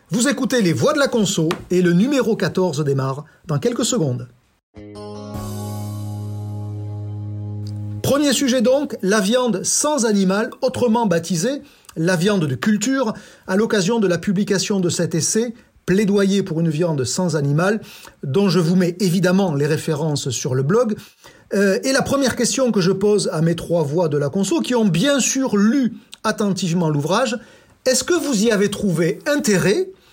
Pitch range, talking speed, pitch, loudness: 155-235 Hz, 160 wpm, 190 Hz, -19 LUFS